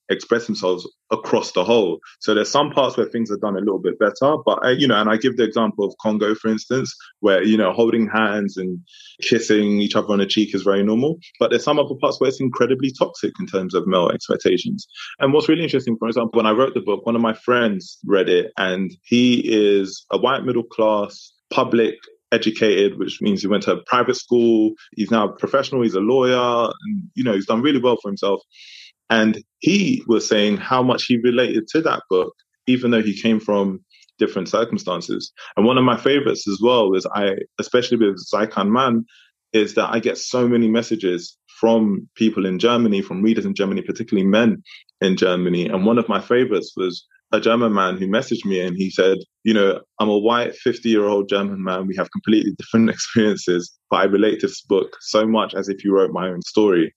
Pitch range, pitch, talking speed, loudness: 100-125 Hz, 110 Hz, 215 wpm, -19 LUFS